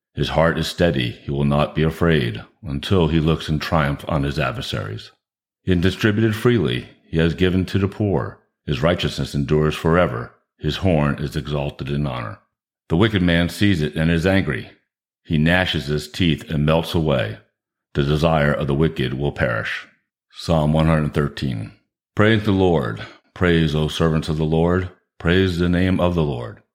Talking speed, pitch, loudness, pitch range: 170 wpm, 80 Hz, -20 LUFS, 75-90 Hz